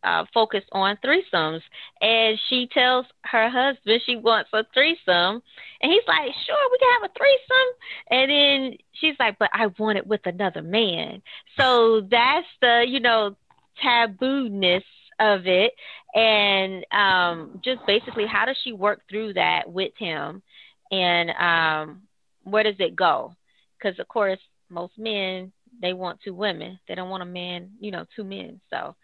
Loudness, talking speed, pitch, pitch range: -21 LUFS, 160 wpm, 215 Hz, 190-250 Hz